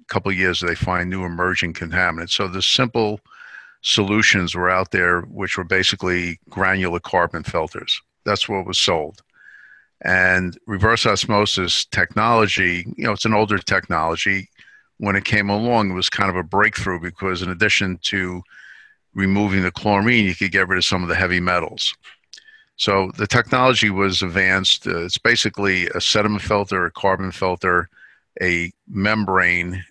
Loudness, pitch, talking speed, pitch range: -19 LUFS, 95 Hz, 155 wpm, 90-105 Hz